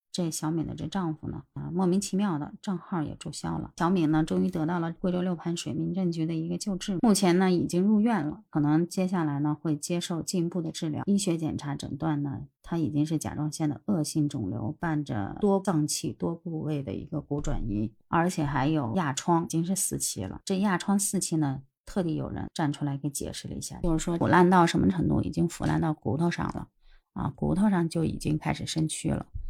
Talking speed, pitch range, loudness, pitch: 325 characters per minute, 150-180 Hz, -28 LUFS, 160 Hz